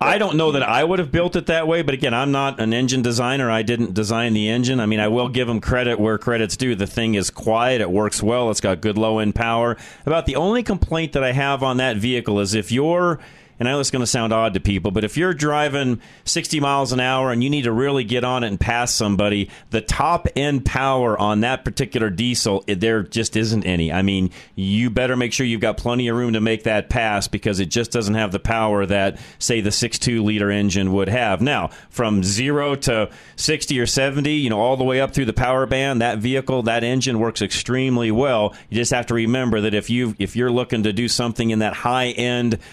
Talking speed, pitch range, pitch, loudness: 240 wpm, 110-130 Hz, 120 Hz, -20 LUFS